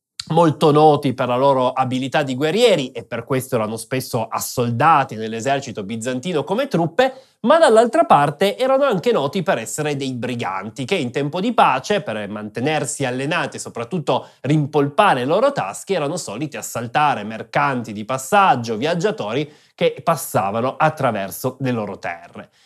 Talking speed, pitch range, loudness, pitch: 145 wpm, 125-170 Hz, -19 LUFS, 140 Hz